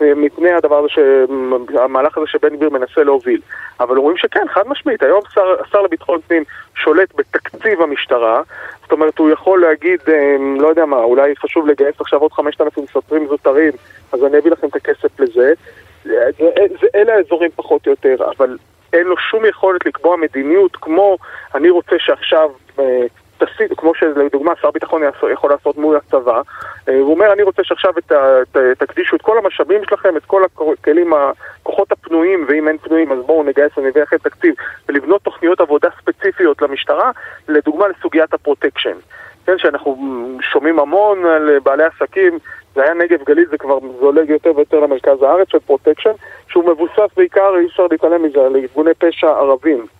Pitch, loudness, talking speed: 170 Hz, -13 LUFS, 160 wpm